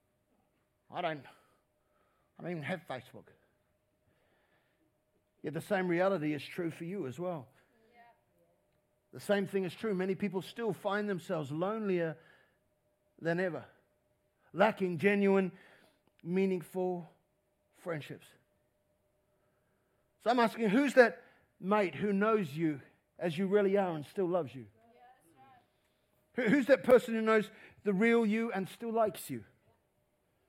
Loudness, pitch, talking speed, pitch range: -32 LUFS, 190 Hz, 125 wpm, 165-215 Hz